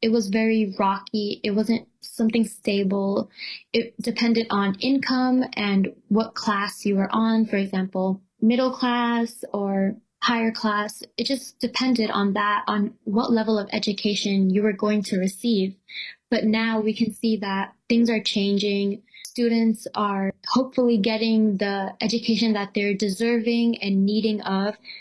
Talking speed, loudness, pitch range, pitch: 145 wpm, -23 LUFS, 200-230 Hz, 215 Hz